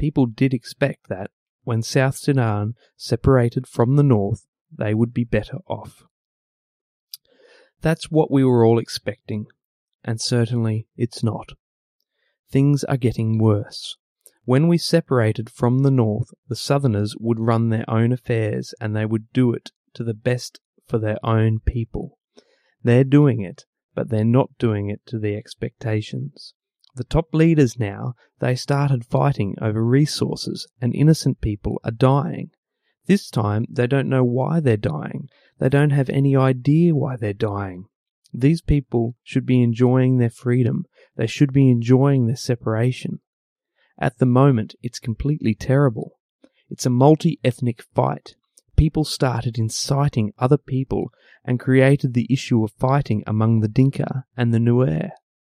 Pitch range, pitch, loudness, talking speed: 115-140 Hz, 125 Hz, -20 LUFS, 150 wpm